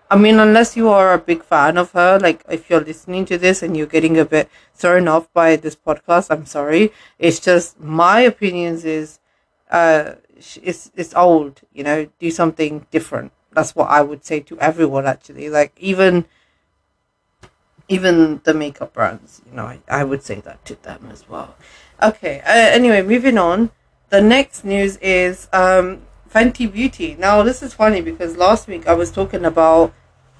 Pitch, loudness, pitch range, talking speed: 170 Hz, -15 LUFS, 155-190 Hz, 180 wpm